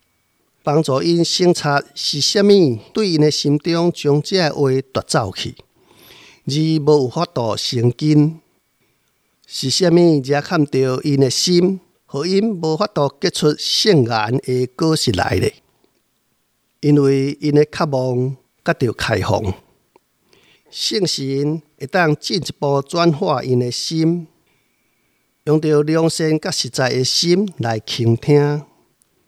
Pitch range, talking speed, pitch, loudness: 130-170 Hz, 175 characters per minute, 150 Hz, -17 LUFS